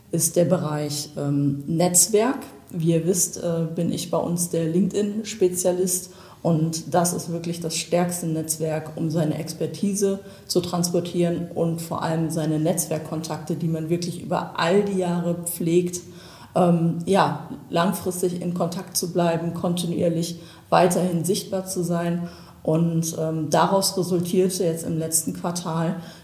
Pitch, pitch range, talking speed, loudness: 170 Hz, 165-180 Hz, 135 wpm, -23 LUFS